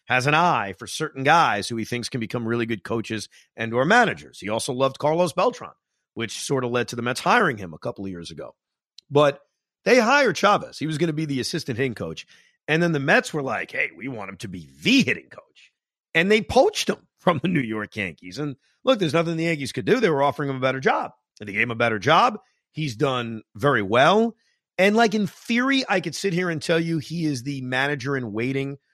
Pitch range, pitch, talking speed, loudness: 115-170 Hz, 140 Hz, 240 wpm, -22 LUFS